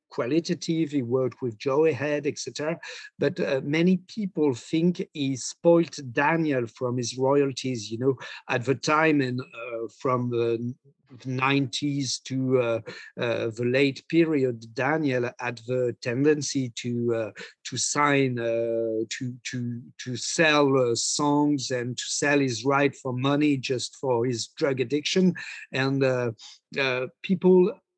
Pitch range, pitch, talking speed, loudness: 125-145 Hz, 135 Hz, 140 wpm, -25 LUFS